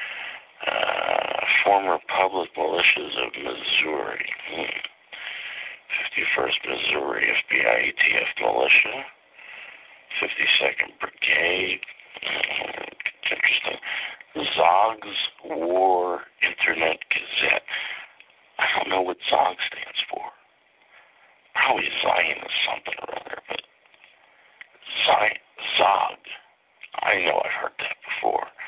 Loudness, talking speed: -22 LUFS, 85 wpm